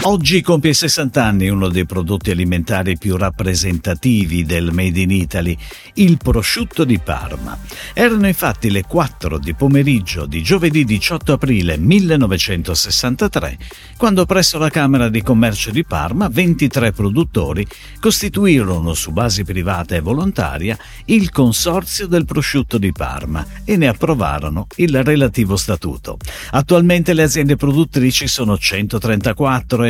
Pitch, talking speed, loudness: 120 Hz, 130 wpm, -15 LUFS